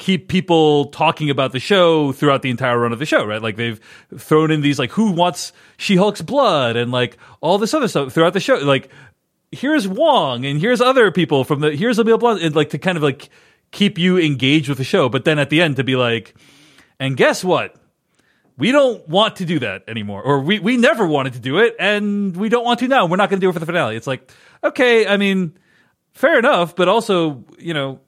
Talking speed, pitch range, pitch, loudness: 235 wpm, 135-200 Hz, 160 Hz, -16 LUFS